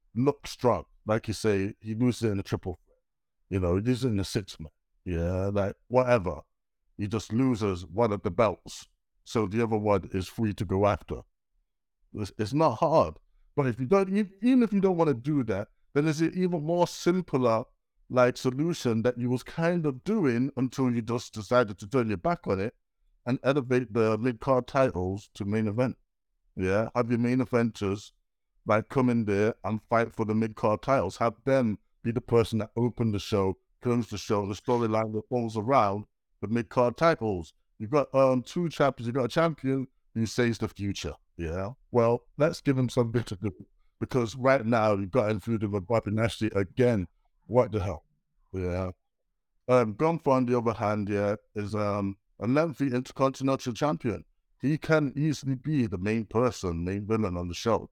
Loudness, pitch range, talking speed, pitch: -28 LUFS, 105-130 Hz, 185 wpm, 115 Hz